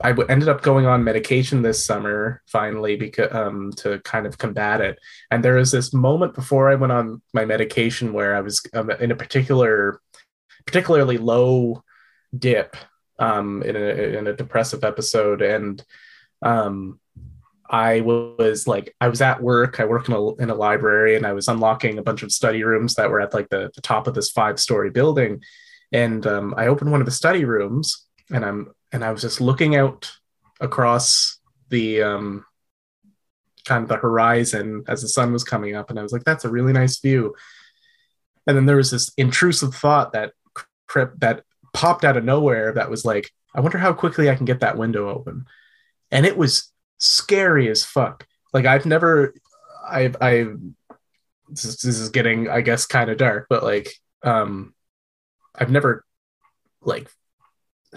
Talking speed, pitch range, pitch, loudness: 180 wpm, 110-135 Hz, 120 Hz, -19 LUFS